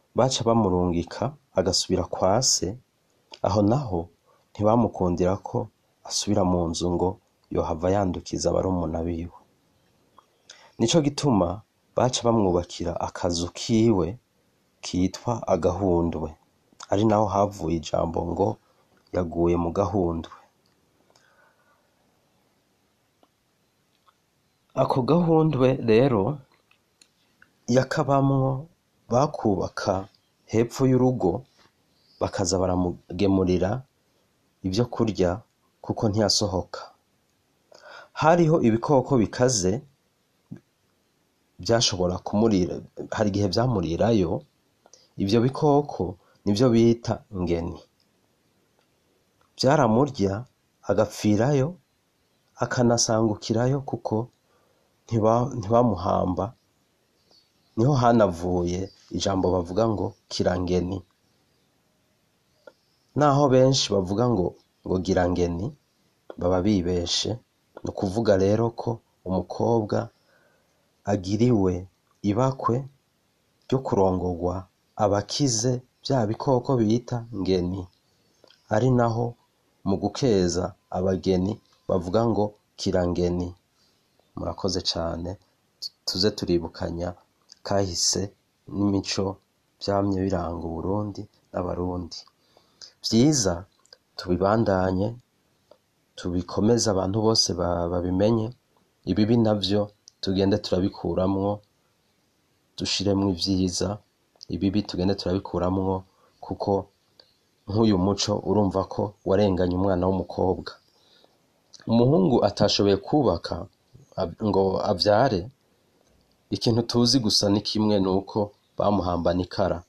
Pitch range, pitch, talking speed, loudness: 90-115 Hz, 100 Hz, 75 wpm, -24 LUFS